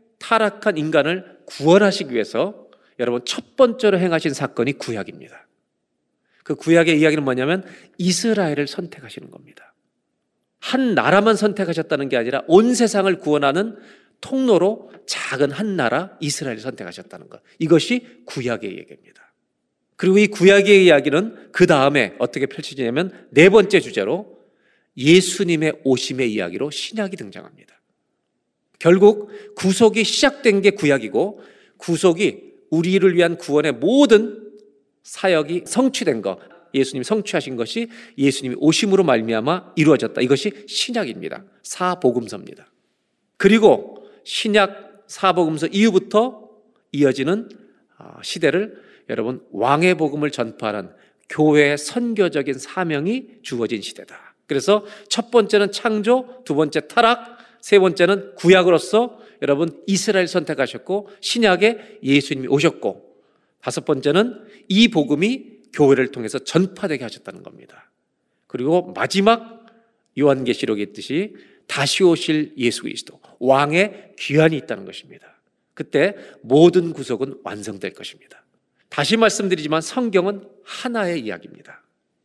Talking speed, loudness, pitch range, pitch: 310 characters per minute, -18 LUFS, 145-210 Hz, 185 Hz